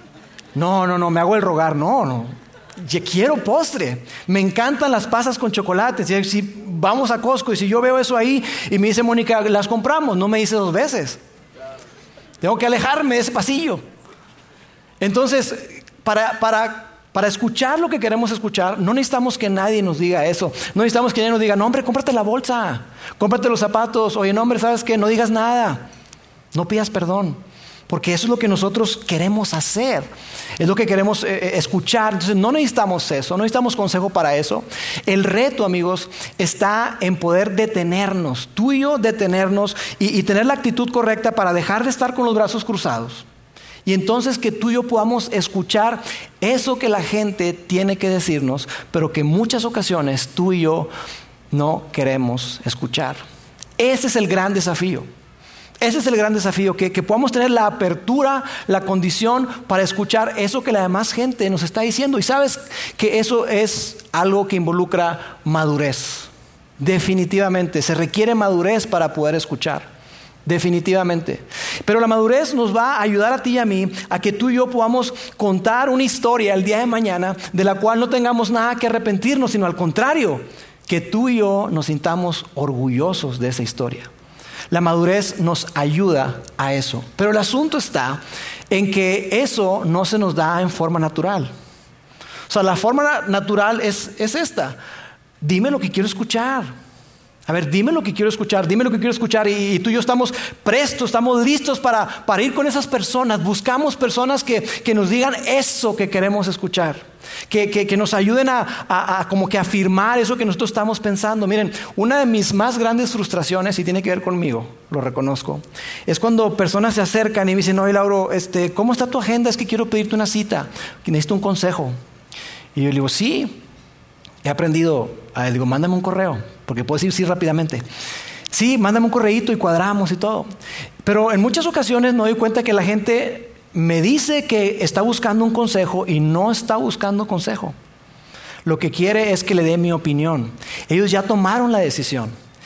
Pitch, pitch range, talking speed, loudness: 205 Hz, 175-230 Hz, 185 wpm, -18 LUFS